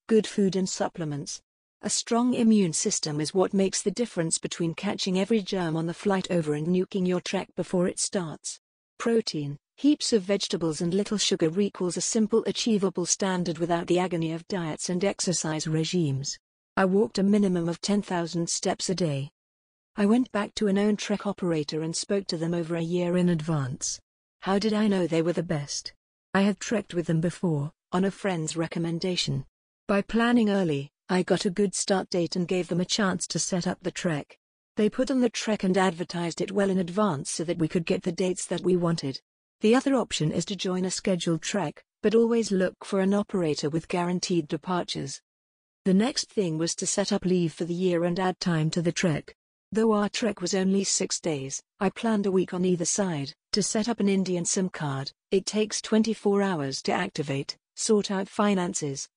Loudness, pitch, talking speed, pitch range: -27 LUFS, 185 Hz, 200 wpm, 170-205 Hz